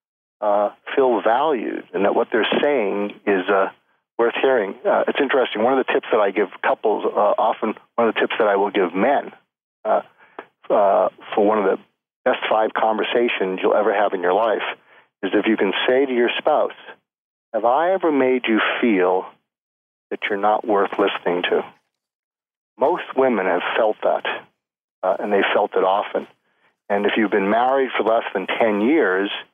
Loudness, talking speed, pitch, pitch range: -20 LUFS, 185 wpm, 110 Hz, 100-130 Hz